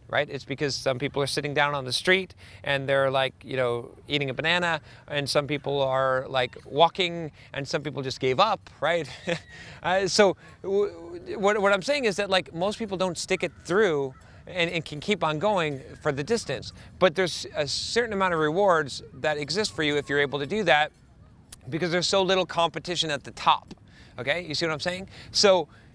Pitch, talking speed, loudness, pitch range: 155 Hz, 200 wpm, -26 LUFS, 135-185 Hz